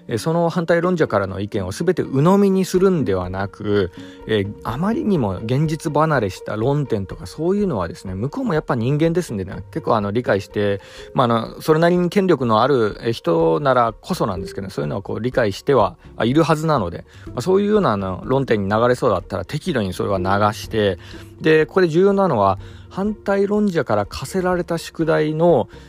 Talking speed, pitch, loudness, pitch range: 395 characters per minute, 130 Hz, -19 LUFS, 100-170 Hz